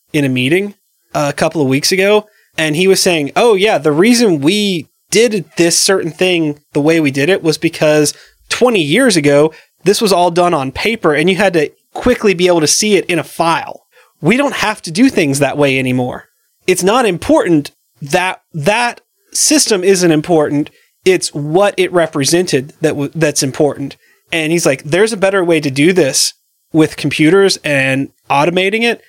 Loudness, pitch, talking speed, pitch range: -12 LUFS, 170 Hz, 185 wpm, 150-195 Hz